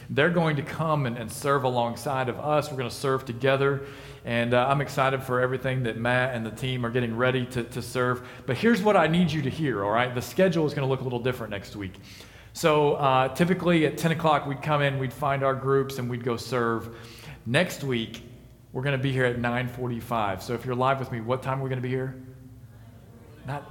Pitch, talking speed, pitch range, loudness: 130 Hz, 240 wpm, 120-140 Hz, -26 LUFS